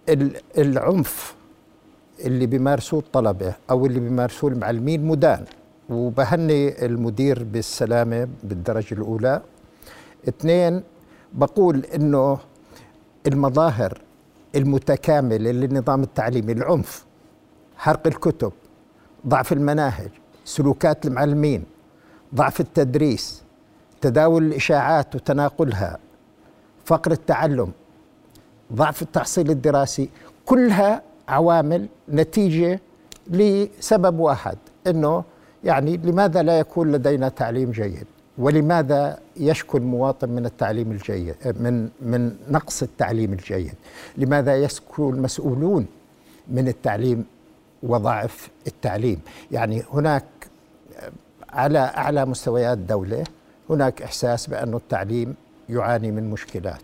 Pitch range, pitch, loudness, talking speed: 120-155 Hz, 135 Hz, -21 LUFS, 85 wpm